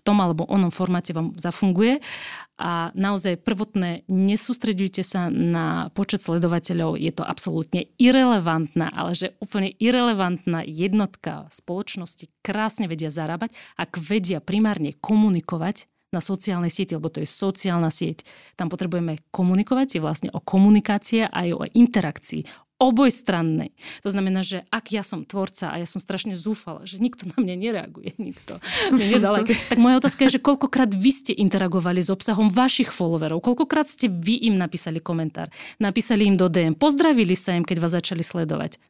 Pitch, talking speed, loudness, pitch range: 195 Hz, 155 wpm, -22 LUFS, 170-220 Hz